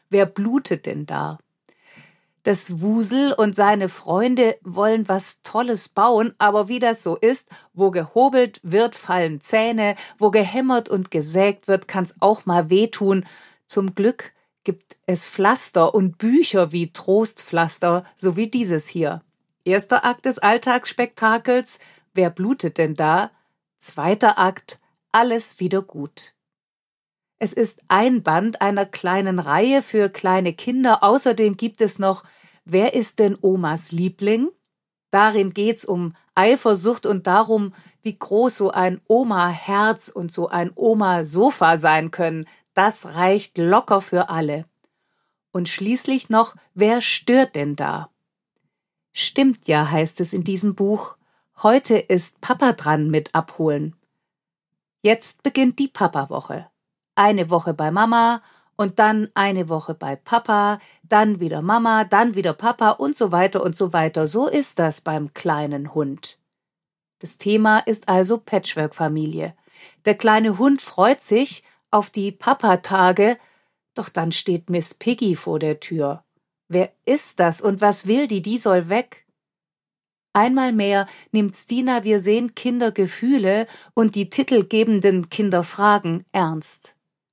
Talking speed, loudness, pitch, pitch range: 135 wpm, -19 LUFS, 200 Hz, 175-225 Hz